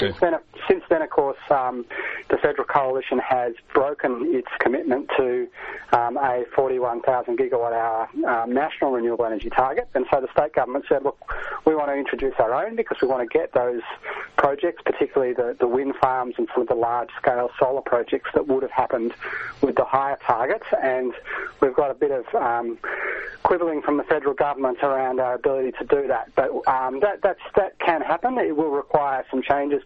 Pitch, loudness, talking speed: 140 Hz, -23 LUFS, 190 wpm